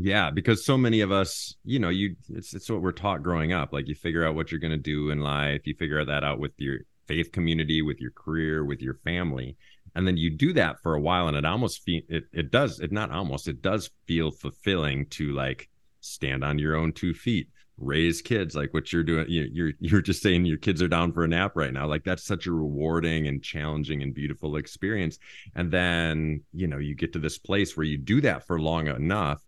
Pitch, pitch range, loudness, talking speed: 80 Hz, 75-90 Hz, -27 LUFS, 235 wpm